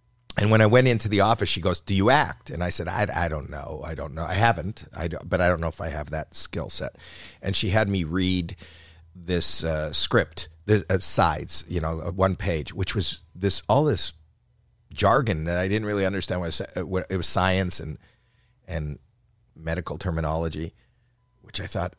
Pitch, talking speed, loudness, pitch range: 90 Hz, 205 wpm, -24 LUFS, 80-100 Hz